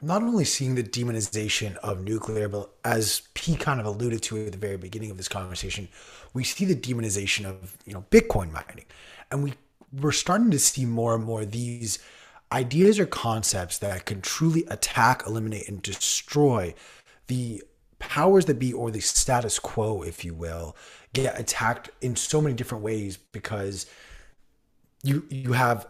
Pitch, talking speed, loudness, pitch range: 115 Hz, 165 wpm, -26 LUFS, 100-135 Hz